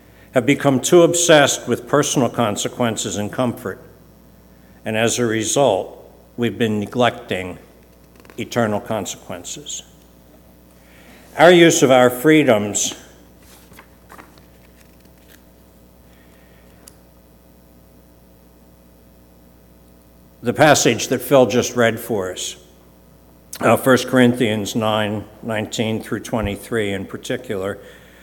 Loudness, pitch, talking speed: -17 LUFS, 95 Hz, 85 wpm